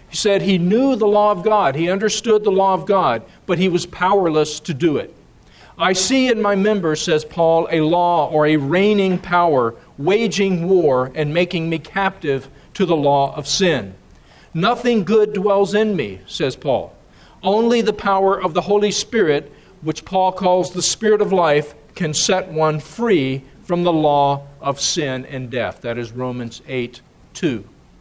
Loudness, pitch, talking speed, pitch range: -18 LUFS, 175 Hz, 175 wpm, 150-200 Hz